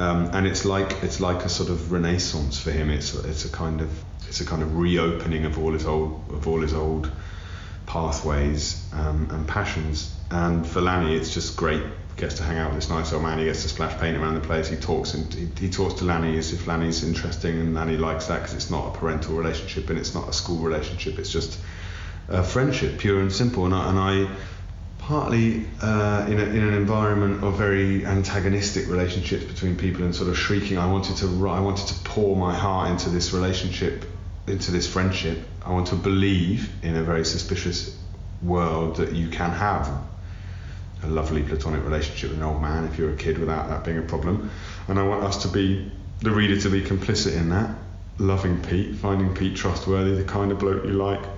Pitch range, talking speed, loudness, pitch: 80-95 Hz, 215 wpm, -25 LUFS, 90 Hz